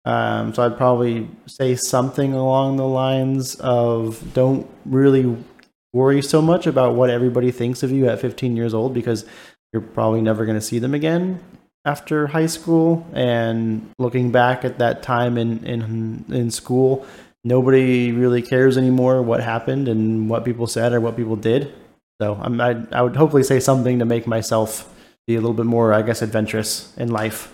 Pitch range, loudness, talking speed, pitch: 115-130 Hz, -19 LUFS, 180 wpm, 120 Hz